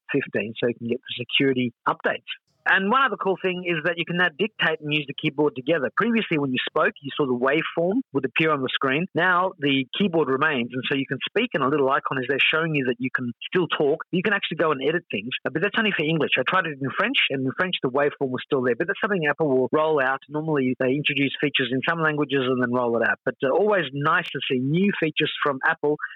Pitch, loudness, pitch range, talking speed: 150 Hz, -23 LUFS, 130-175 Hz, 255 wpm